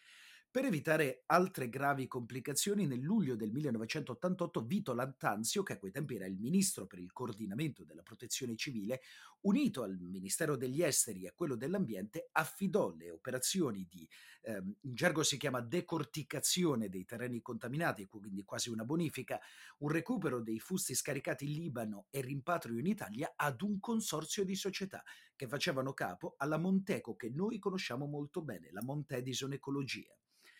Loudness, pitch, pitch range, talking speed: -38 LUFS, 145 Hz, 125-180 Hz, 155 wpm